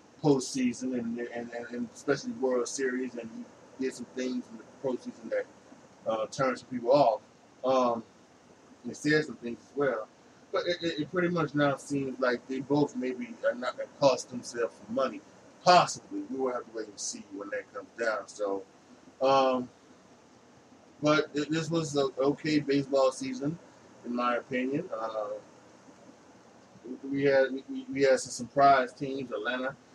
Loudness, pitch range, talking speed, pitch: -30 LUFS, 125-150 Hz, 165 wpm, 135 Hz